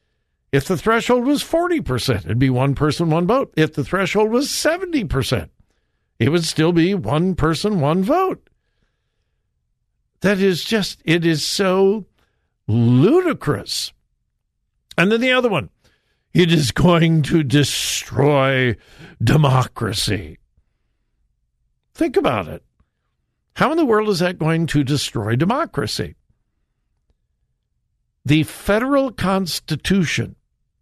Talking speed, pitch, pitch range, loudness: 115 wpm, 165 Hz, 140-210 Hz, -18 LUFS